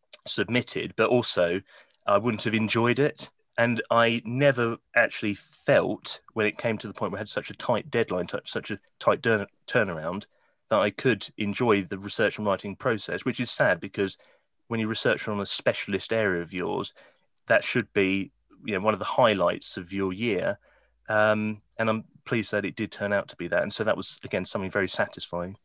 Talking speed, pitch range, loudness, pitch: 200 wpm, 100-115 Hz, -27 LUFS, 105 Hz